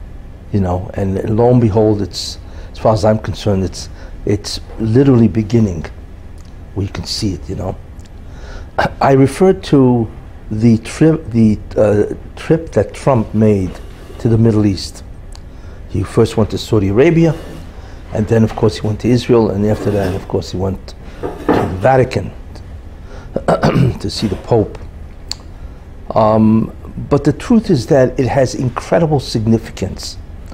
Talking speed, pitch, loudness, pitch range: 150 wpm, 100 Hz, -14 LUFS, 85-115 Hz